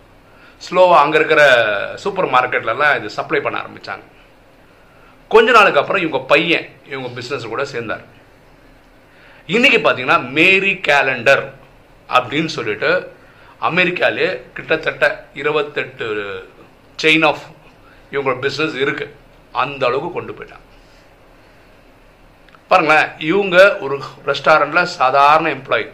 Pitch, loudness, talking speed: 155 Hz, -15 LUFS, 95 wpm